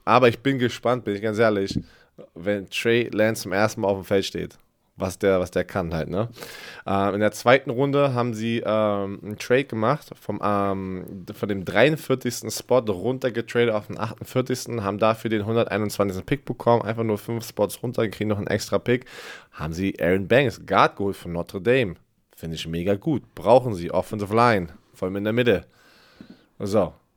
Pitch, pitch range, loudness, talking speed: 105 Hz, 100-120 Hz, -23 LUFS, 190 wpm